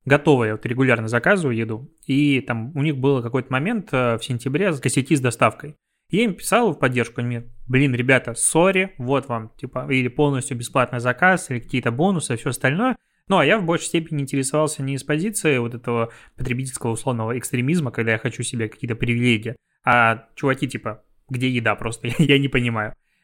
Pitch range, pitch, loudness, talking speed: 120-150 Hz, 130 Hz, -21 LUFS, 185 wpm